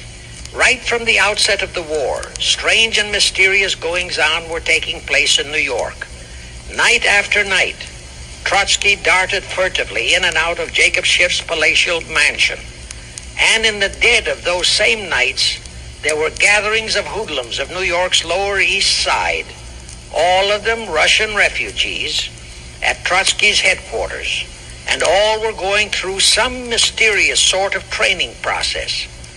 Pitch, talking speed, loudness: 180 Hz, 140 wpm, -14 LUFS